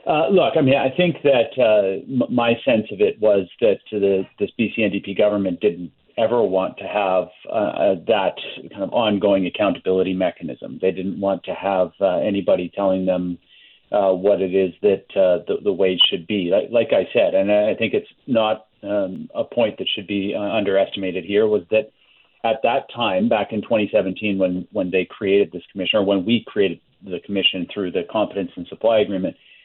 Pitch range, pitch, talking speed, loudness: 95-110 Hz, 100 Hz, 190 wpm, -20 LUFS